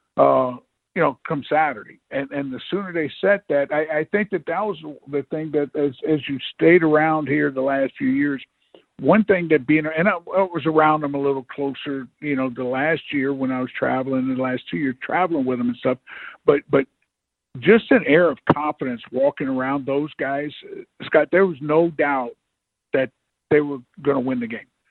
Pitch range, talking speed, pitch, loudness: 135-165 Hz, 210 wpm, 145 Hz, -21 LUFS